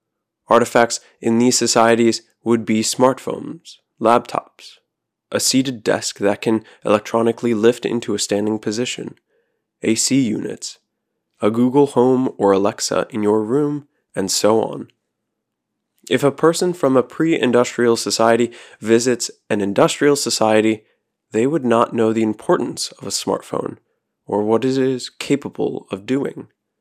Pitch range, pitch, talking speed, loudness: 110-130 Hz, 115 Hz, 135 wpm, -18 LUFS